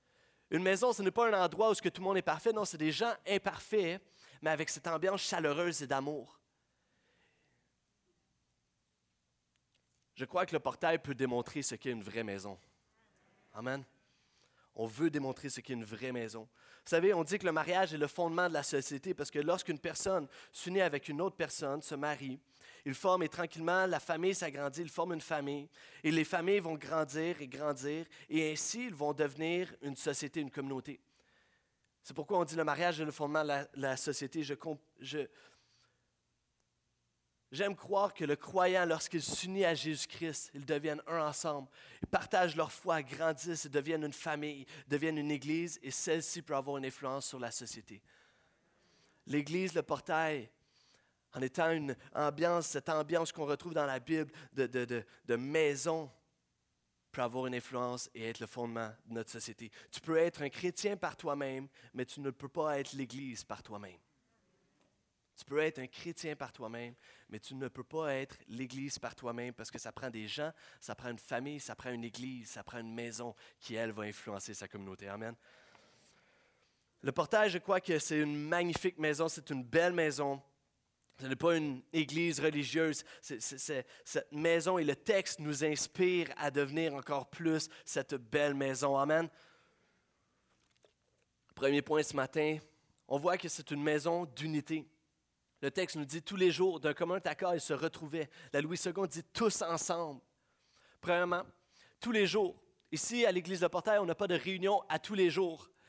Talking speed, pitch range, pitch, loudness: 180 wpm, 135-170 Hz, 150 Hz, -36 LUFS